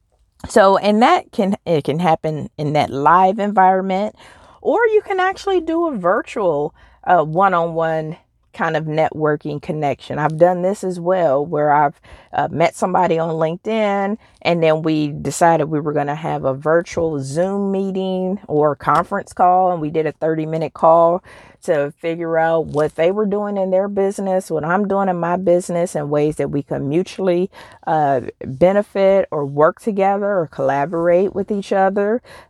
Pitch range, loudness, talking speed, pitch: 155-195 Hz, -18 LUFS, 170 wpm, 170 Hz